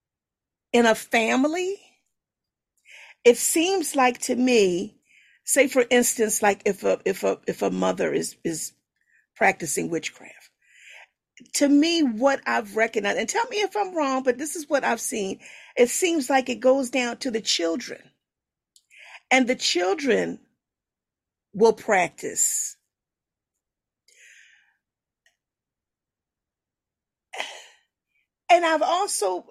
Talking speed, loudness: 115 wpm, -23 LUFS